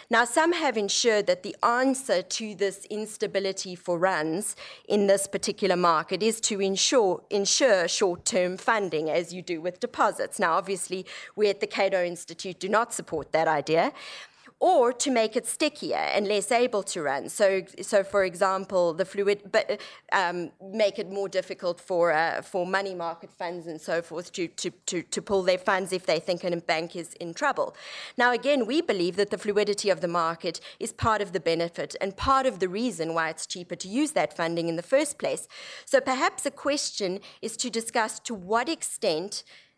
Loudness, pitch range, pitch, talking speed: -26 LUFS, 180-225 Hz, 195 Hz, 190 wpm